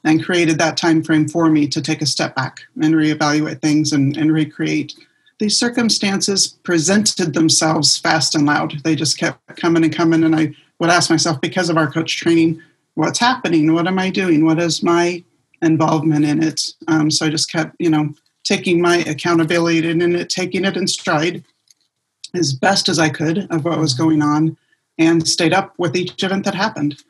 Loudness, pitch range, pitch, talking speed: -16 LUFS, 155-175 Hz, 165 Hz, 195 wpm